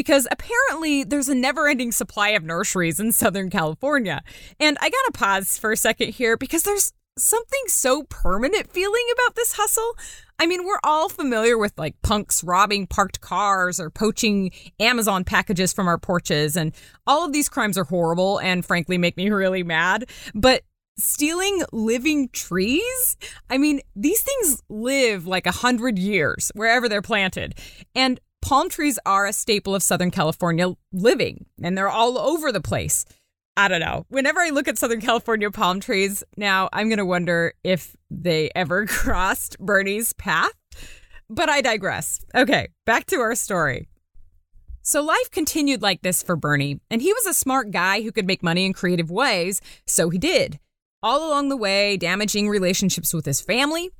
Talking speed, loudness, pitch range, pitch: 170 wpm, -21 LUFS, 185-285 Hz, 215 Hz